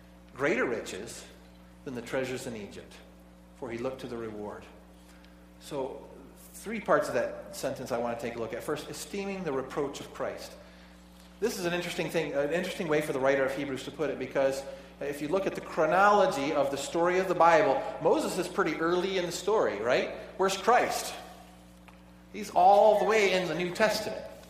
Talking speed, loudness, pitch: 195 wpm, -29 LUFS, 140 Hz